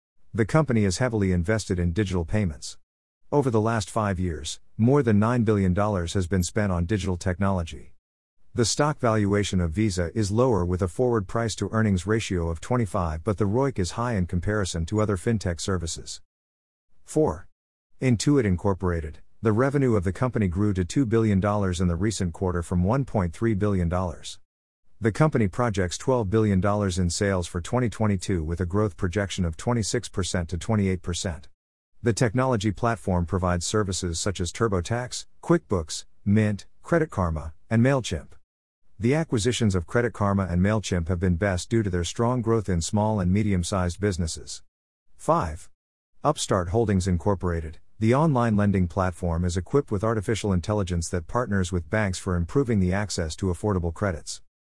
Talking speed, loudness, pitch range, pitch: 160 wpm, -25 LUFS, 90-110 Hz, 100 Hz